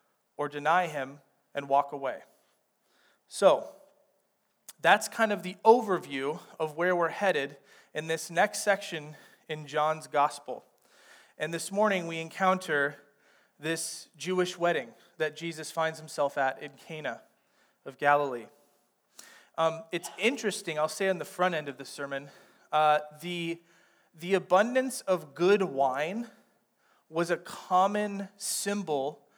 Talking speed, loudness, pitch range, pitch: 130 wpm, -29 LUFS, 150-190 Hz, 165 Hz